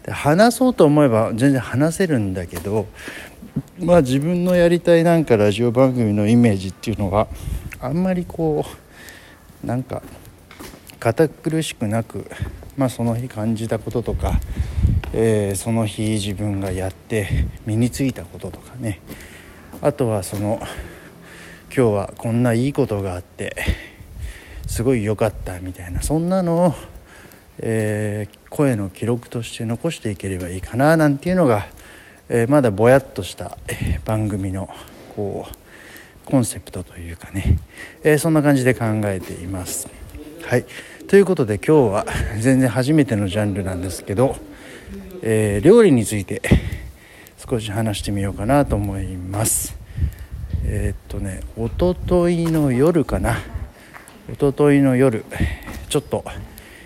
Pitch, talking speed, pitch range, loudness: 110 Hz, 280 characters per minute, 95-135 Hz, -20 LUFS